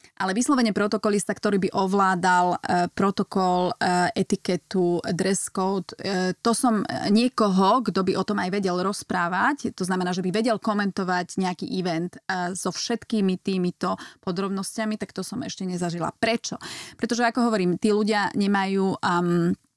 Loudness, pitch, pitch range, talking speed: -24 LUFS, 195 Hz, 180-215 Hz, 150 wpm